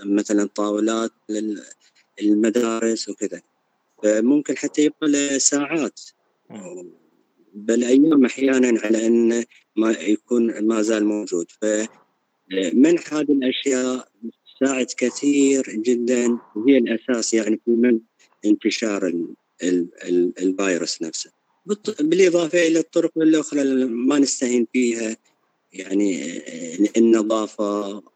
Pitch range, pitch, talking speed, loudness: 110-140 Hz, 120 Hz, 95 wpm, -20 LUFS